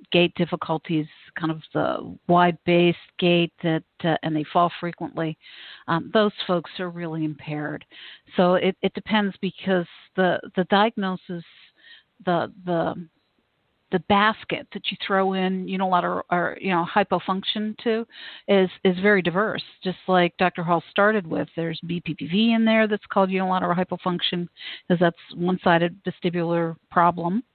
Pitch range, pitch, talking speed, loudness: 170-195 Hz, 180 Hz, 145 wpm, -23 LUFS